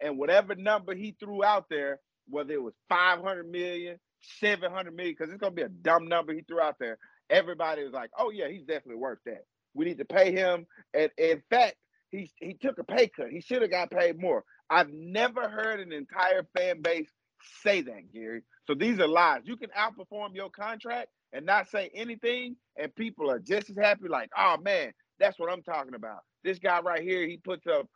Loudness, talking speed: -29 LUFS, 215 wpm